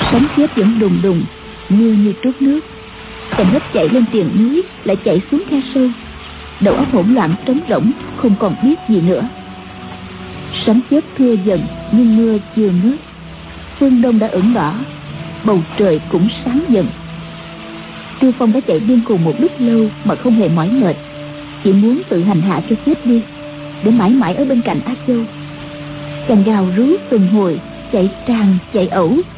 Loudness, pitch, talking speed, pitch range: -14 LUFS, 220 Hz, 180 wpm, 185-250 Hz